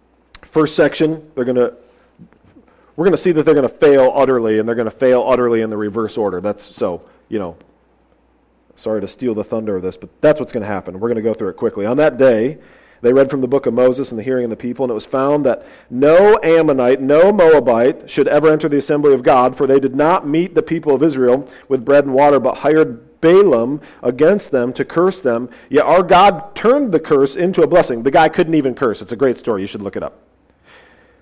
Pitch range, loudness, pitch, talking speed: 125-155 Hz, -14 LUFS, 135 Hz, 240 wpm